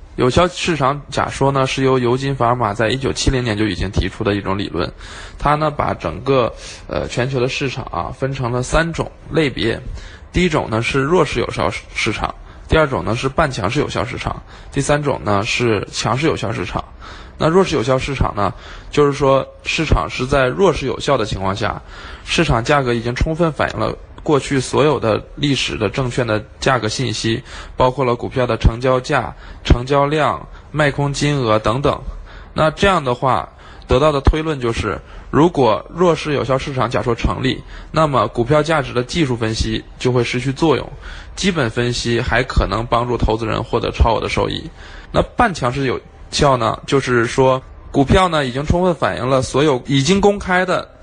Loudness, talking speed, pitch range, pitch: -17 LUFS, 275 characters per minute, 110-140 Hz, 125 Hz